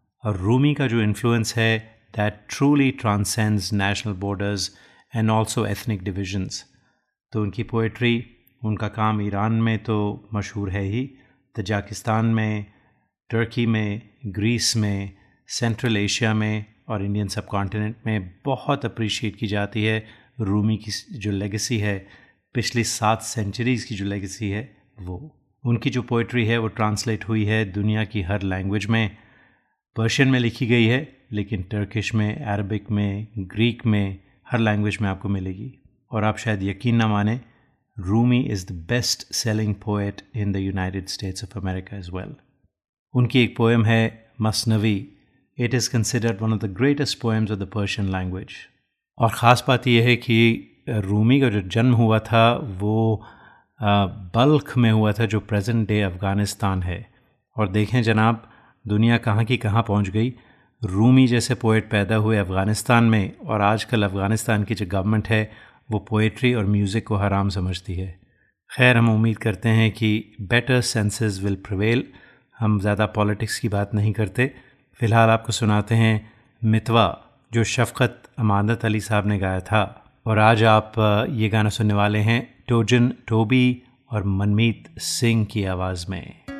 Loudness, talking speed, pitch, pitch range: -22 LUFS, 155 wpm, 110 Hz, 105-115 Hz